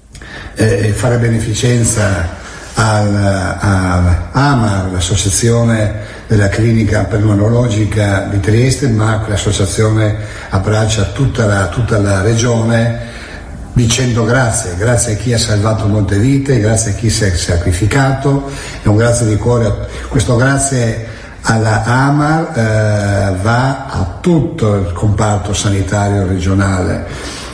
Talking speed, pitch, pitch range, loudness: 110 wpm, 110 Hz, 100-120 Hz, -13 LUFS